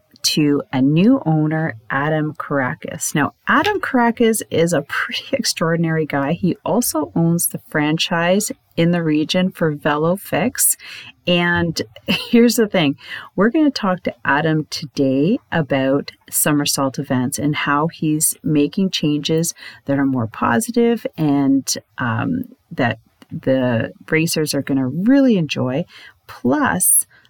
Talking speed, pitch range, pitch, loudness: 125 wpm, 140-185 Hz, 160 Hz, -18 LUFS